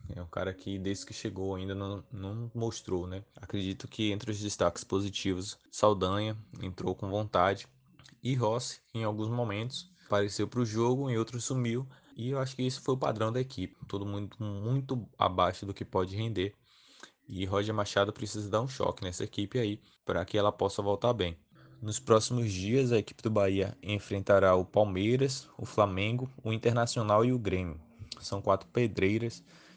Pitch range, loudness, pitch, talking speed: 95-120 Hz, -32 LUFS, 105 Hz, 175 wpm